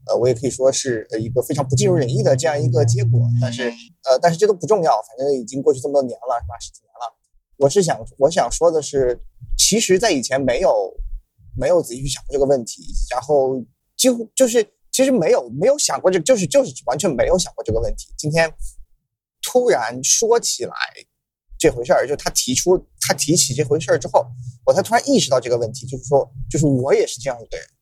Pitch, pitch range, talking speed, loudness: 145 Hz, 125-200 Hz, 330 characters per minute, -18 LUFS